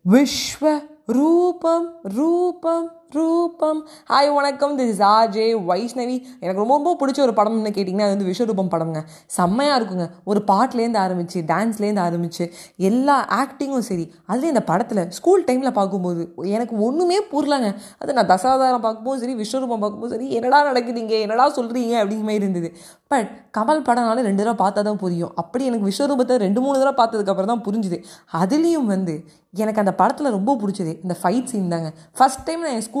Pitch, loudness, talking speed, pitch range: 225 Hz, -20 LUFS, 155 wpm, 195-275 Hz